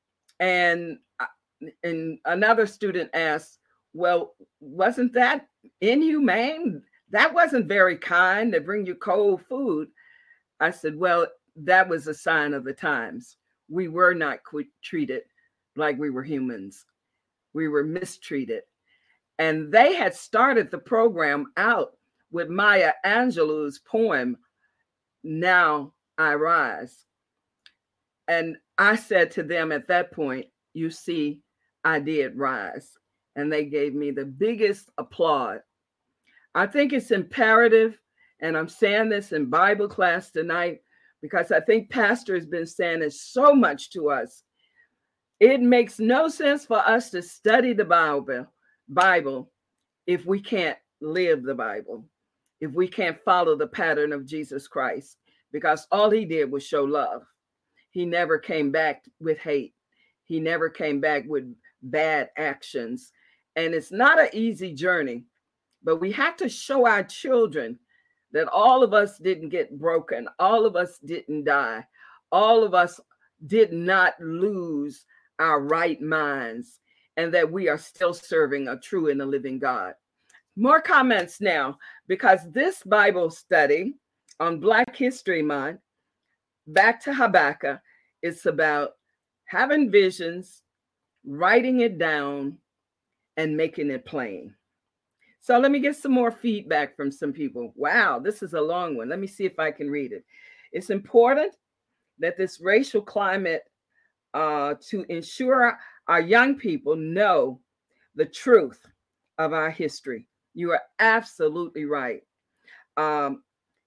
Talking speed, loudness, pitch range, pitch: 140 wpm, -23 LUFS, 155-230 Hz, 180 Hz